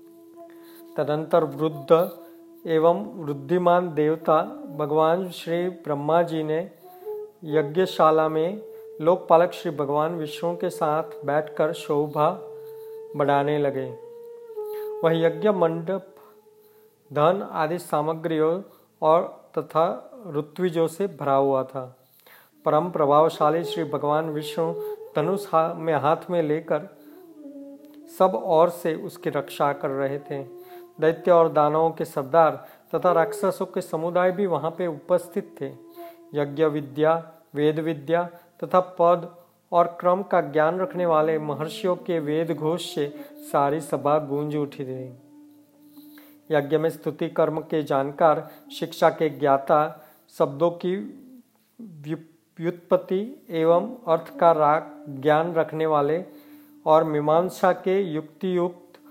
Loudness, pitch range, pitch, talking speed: -24 LUFS, 155-185 Hz, 165 Hz, 115 wpm